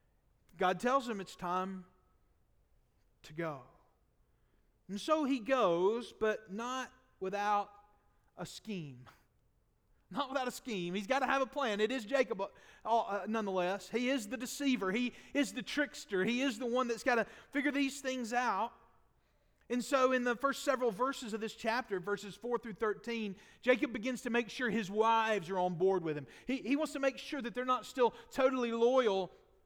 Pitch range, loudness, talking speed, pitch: 205-260 Hz, -35 LUFS, 180 wpm, 235 Hz